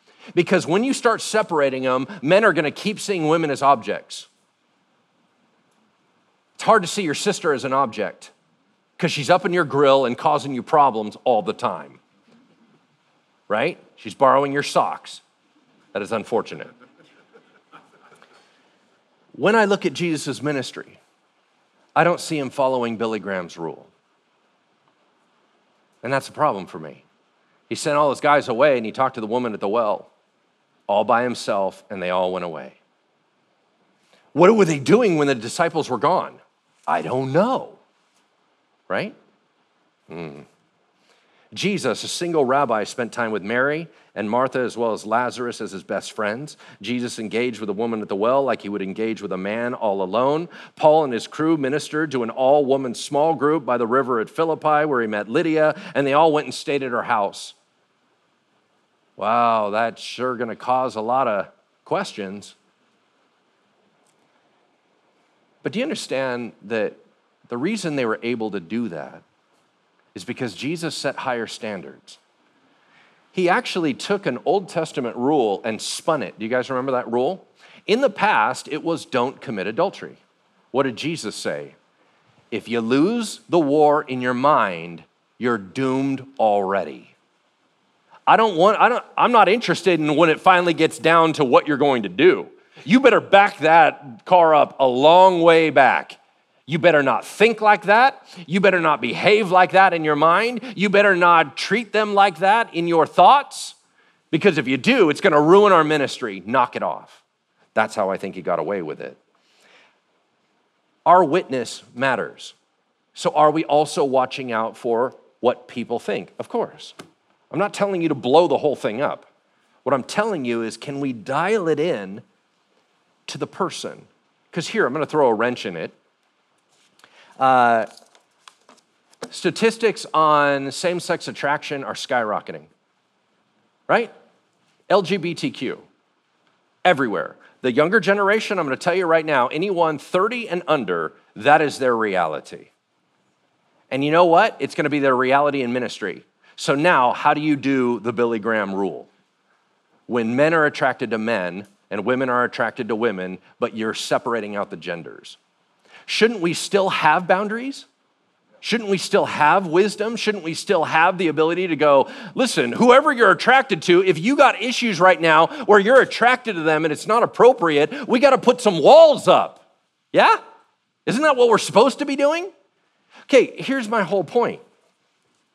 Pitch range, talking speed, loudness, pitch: 125-195 Hz, 165 wpm, -19 LUFS, 150 Hz